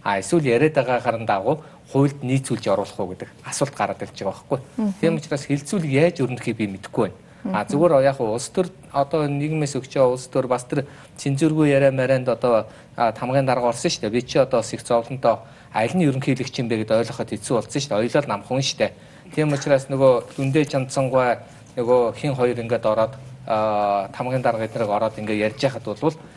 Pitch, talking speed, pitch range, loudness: 130 Hz, 185 wpm, 120-145 Hz, -22 LUFS